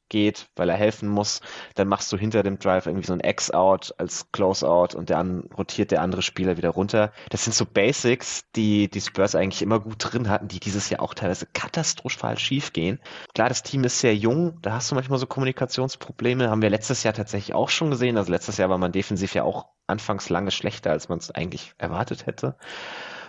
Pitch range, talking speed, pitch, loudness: 100-125 Hz, 210 wpm, 105 Hz, -24 LUFS